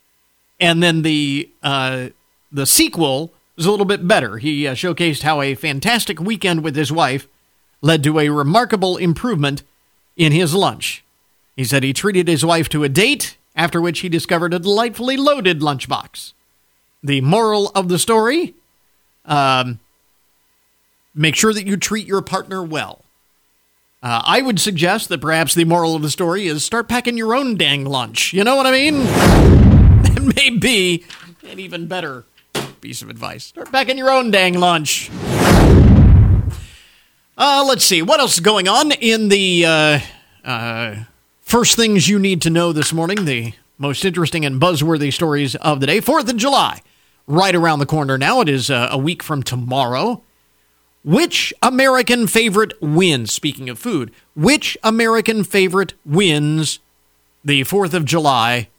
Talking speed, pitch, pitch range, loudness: 160 wpm, 170 Hz, 145-205 Hz, -15 LUFS